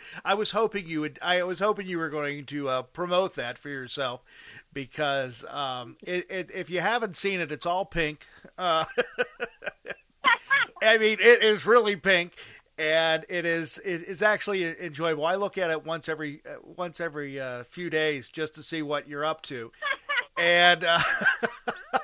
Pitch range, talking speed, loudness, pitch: 150-195 Hz, 165 wpm, -26 LUFS, 170 Hz